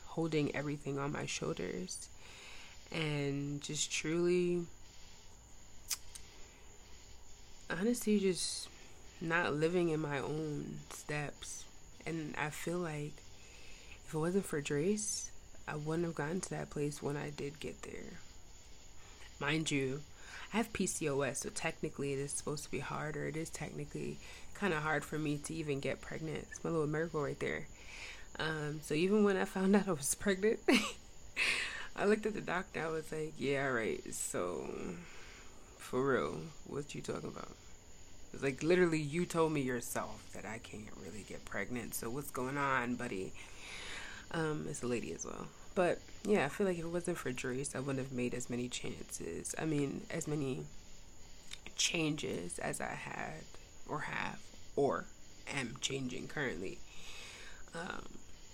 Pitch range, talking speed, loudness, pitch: 120-160 Hz, 155 wpm, -38 LUFS, 145 Hz